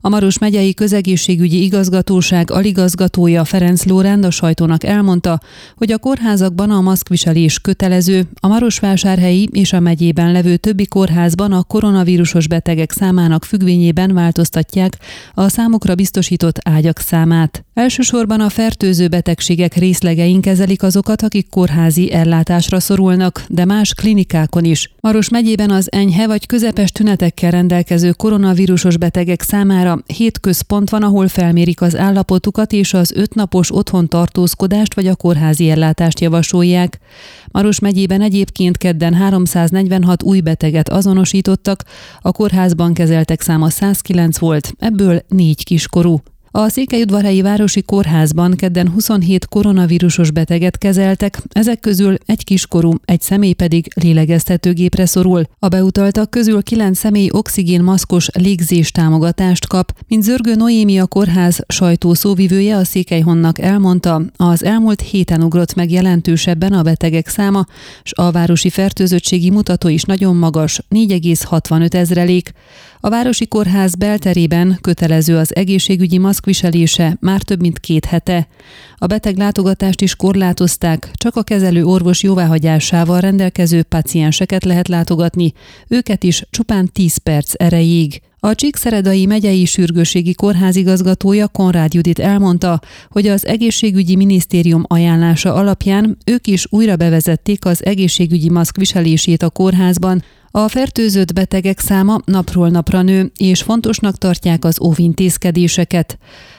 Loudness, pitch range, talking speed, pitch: -12 LUFS, 170-200 Hz, 125 wpm, 185 Hz